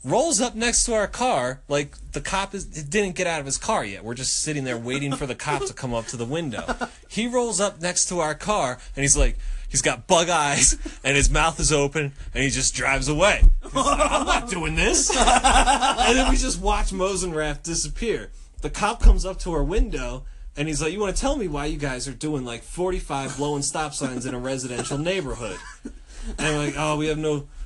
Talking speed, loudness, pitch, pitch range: 225 wpm, -23 LUFS, 150 Hz, 135-190 Hz